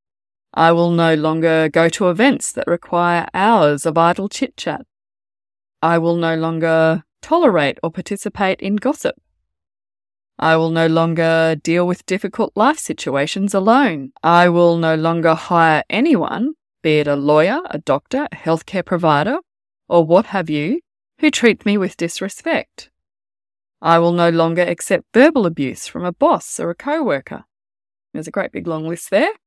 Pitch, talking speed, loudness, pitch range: 170 Hz, 155 wpm, -16 LUFS, 155-200 Hz